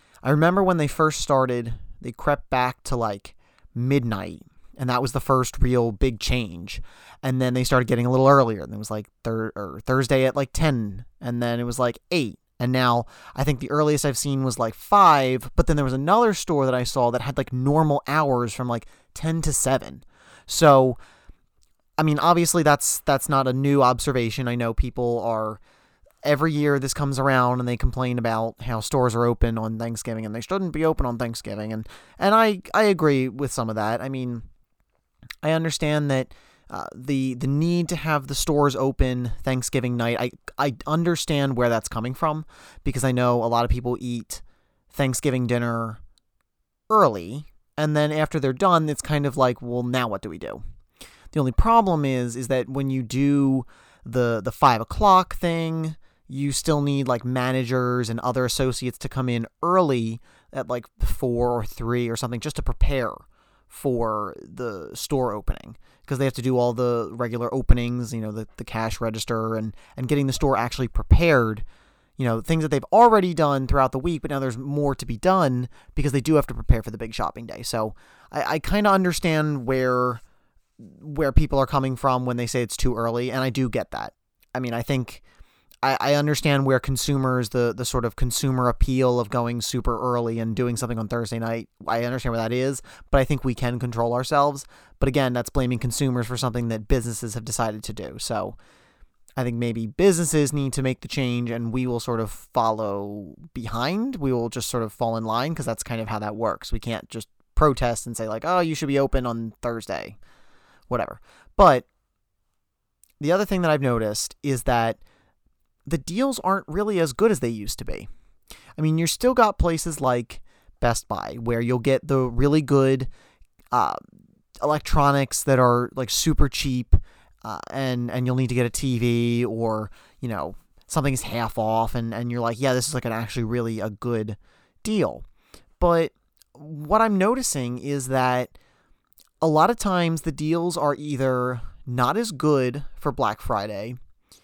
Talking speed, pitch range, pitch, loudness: 195 wpm, 120-145 Hz, 125 Hz, -23 LUFS